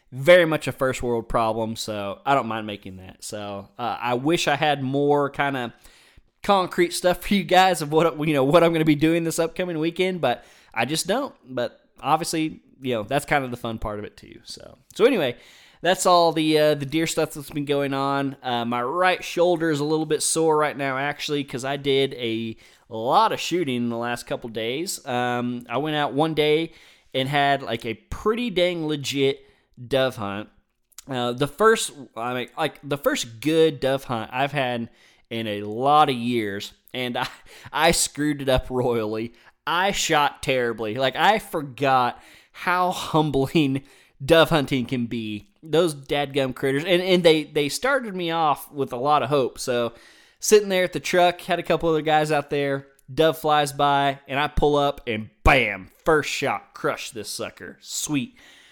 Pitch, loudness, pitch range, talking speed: 140 Hz, -23 LUFS, 125-160 Hz, 195 wpm